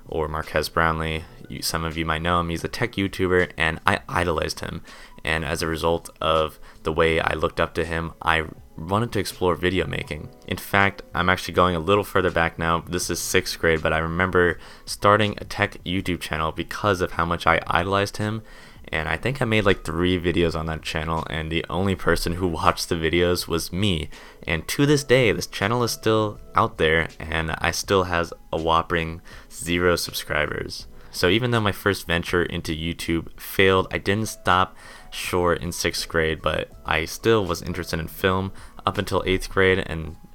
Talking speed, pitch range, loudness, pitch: 195 wpm, 80-95 Hz, -23 LUFS, 85 Hz